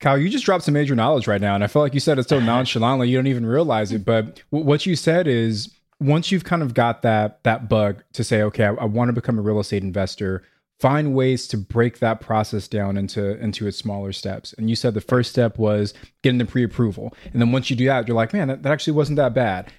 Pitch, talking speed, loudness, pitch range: 120 Hz, 265 wpm, -20 LUFS, 105-135 Hz